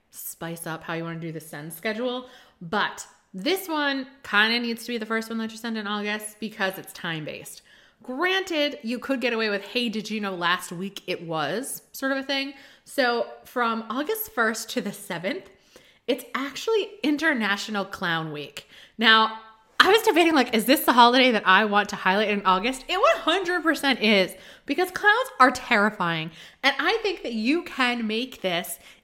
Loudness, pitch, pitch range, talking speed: -24 LUFS, 225 Hz, 195-275 Hz, 190 wpm